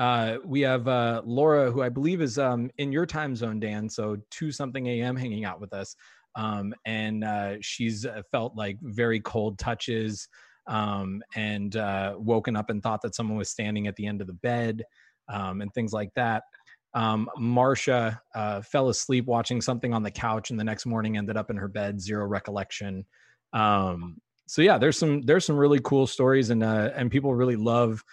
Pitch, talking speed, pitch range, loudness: 110 Hz, 195 wpm, 105-125 Hz, -27 LUFS